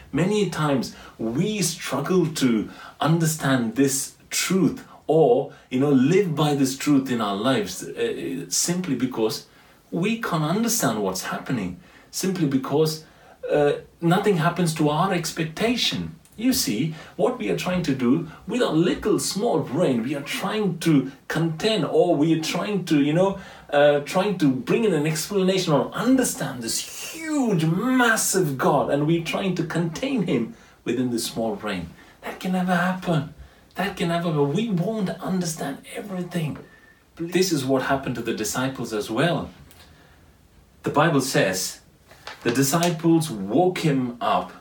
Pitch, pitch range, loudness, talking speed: 165 Hz, 140-190 Hz, -23 LUFS, 150 wpm